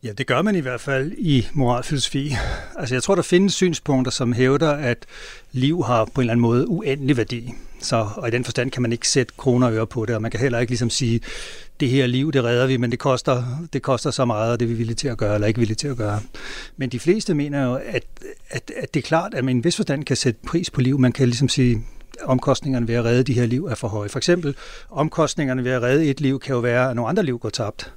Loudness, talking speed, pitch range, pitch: -21 LUFS, 275 wpm, 120-140 Hz, 130 Hz